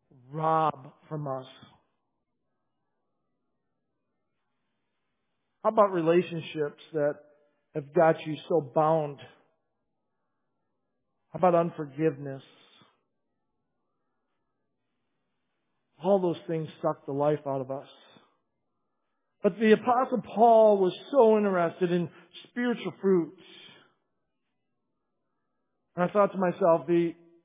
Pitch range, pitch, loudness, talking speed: 150-180 Hz, 165 Hz, -26 LUFS, 85 wpm